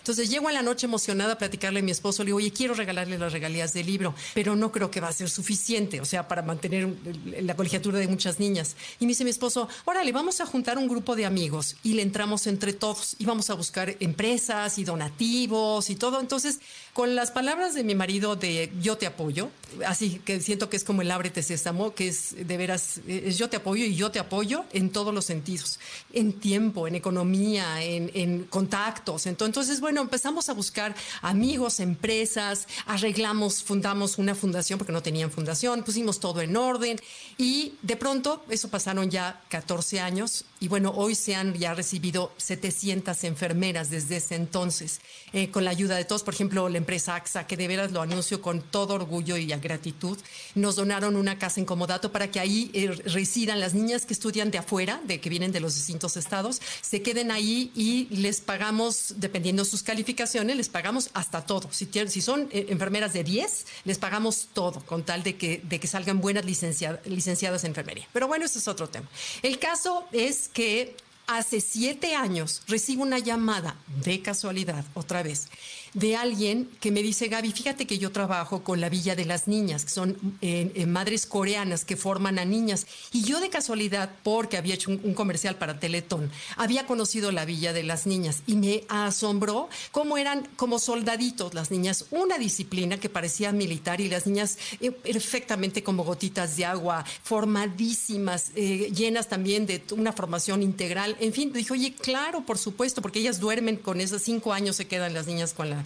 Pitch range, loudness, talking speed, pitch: 180-225 Hz, -27 LUFS, 195 wpm, 200 Hz